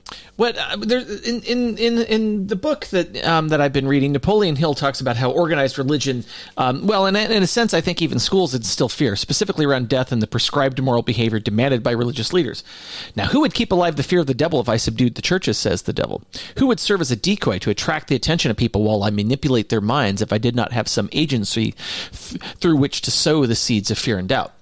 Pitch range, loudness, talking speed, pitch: 120-185 Hz, -19 LUFS, 235 wpm, 140 Hz